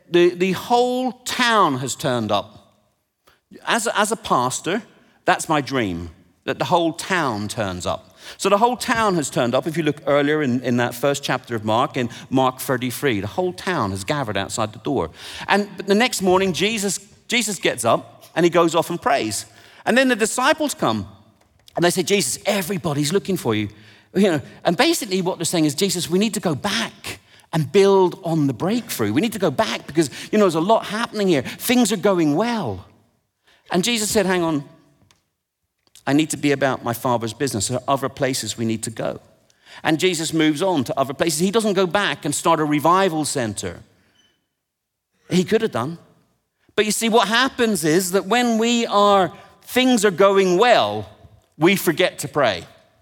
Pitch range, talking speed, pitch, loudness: 120-200 Hz, 195 wpm, 165 Hz, -20 LUFS